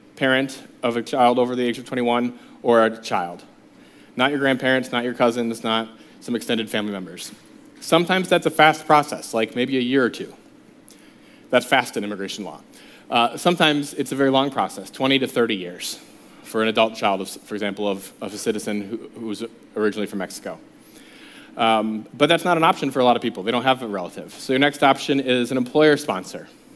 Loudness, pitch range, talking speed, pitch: -21 LUFS, 110-140 Hz, 200 wpm, 125 Hz